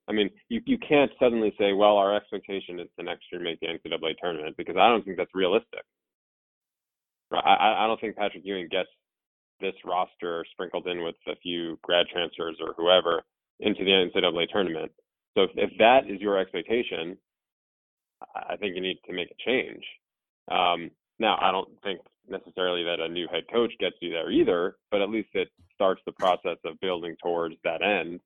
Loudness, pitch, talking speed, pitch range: -26 LUFS, 95 Hz, 185 wpm, 85-105 Hz